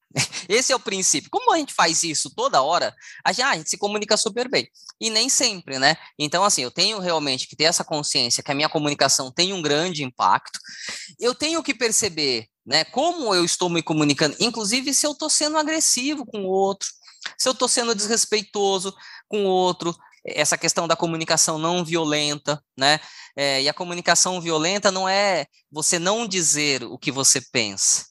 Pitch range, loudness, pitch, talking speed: 155-220 Hz, -21 LUFS, 180 Hz, 185 wpm